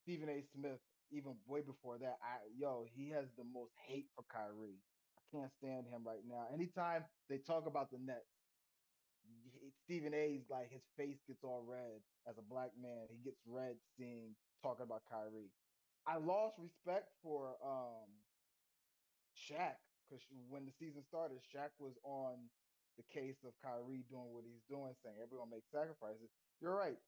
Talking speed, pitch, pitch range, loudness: 165 wpm, 130 Hz, 120-145 Hz, -49 LUFS